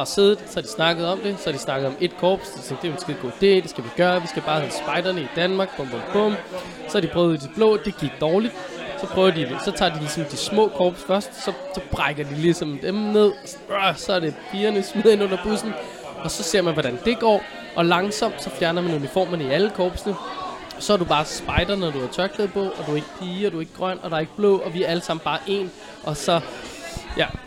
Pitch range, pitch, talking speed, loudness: 160-200 Hz, 180 Hz, 260 wpm, -23 LUFS